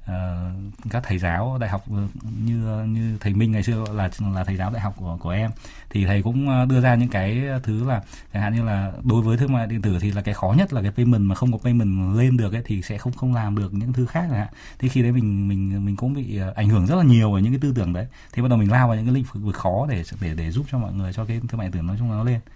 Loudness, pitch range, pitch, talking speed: -22 LUFS, 100-120 Hz, 110 Hz, 300 wpm